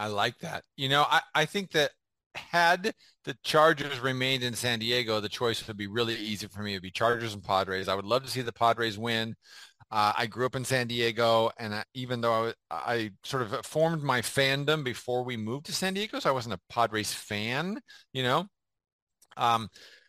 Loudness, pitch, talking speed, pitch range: -29 LUFS, 120 Hz, 215 wpm, 110-140 Hz